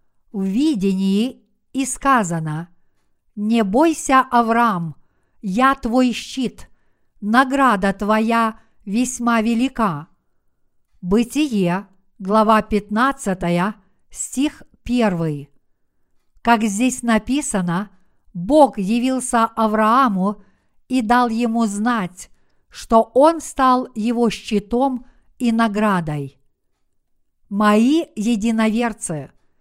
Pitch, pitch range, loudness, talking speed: 225 Hz, 195-245 Hz, -18 LUFS, 75 wpm